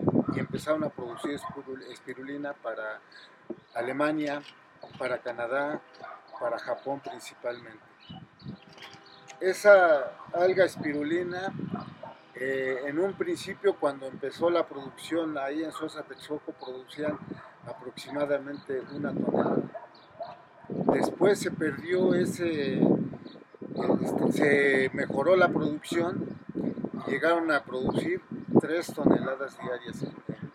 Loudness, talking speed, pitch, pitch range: -29 LUFS, 90 wpm, 150 Hz, 140-180 Hz